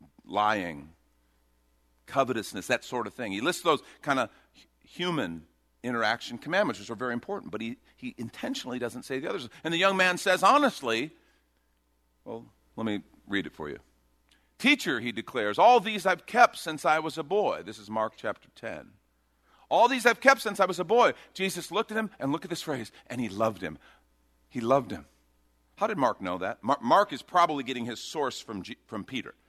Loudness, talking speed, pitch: -28 LUFS, 195 wpm, 125 Hz